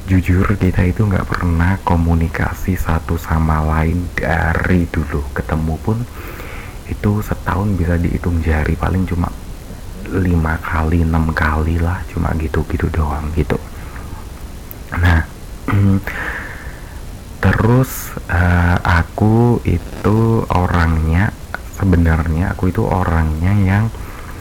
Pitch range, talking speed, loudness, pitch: 80-95 Hz, 100 wpm, -17 LUFS, 85 Hz